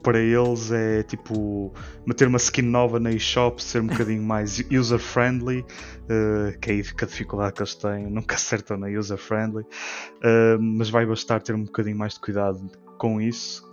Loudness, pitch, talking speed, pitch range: -24 LUFS, 110 Hz, 185 wpm, 105-115 Hz